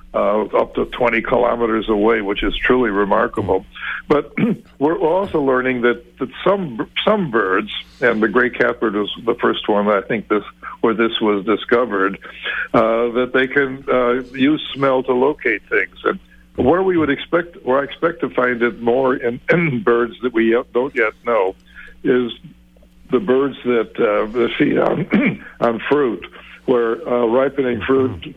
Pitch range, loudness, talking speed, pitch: 115-130 Hz, -18 LUFS, 165 wpm, 120 Hz